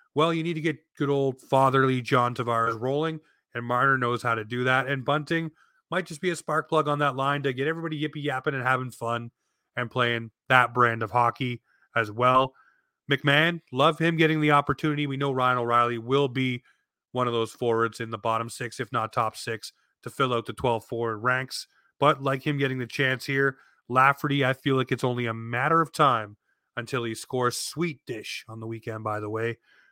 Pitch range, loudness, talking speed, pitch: 120-145 Hz, -26 LUFS, 205 wpm, 130 Hz